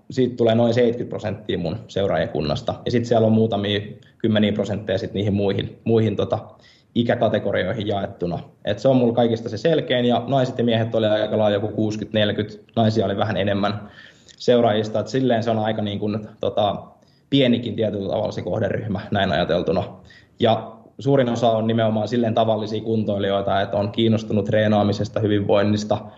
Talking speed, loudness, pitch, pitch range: 155 wpm, -21 LUFS, 110 Hz, 105-115 Hz